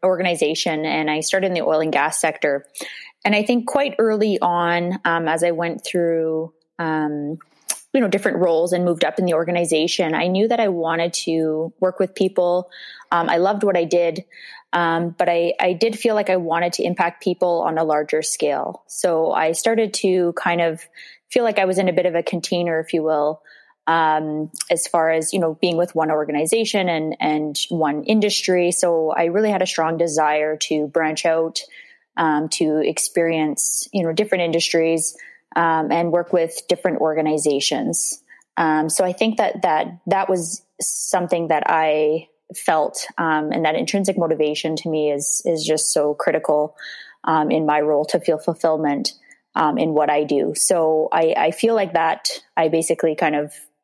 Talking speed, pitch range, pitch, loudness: 185 wpm, 155-180 Hz, 165 Hz, -20 LUFS